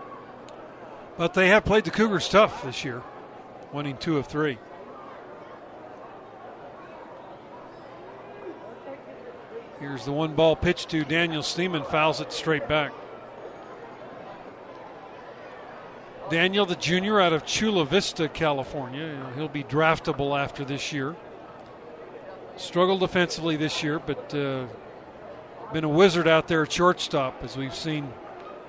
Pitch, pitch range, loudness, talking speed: 155 Hz, 145-175 Hz, -24 LUFS, 115 wpm